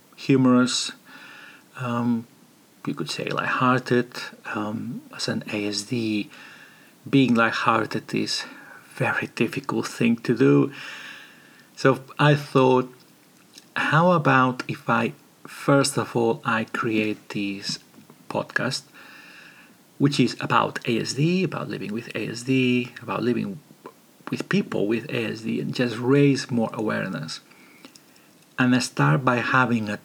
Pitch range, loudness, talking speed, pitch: 115-135 Hz, -23 LUFS, 120 wpm, 125 Hz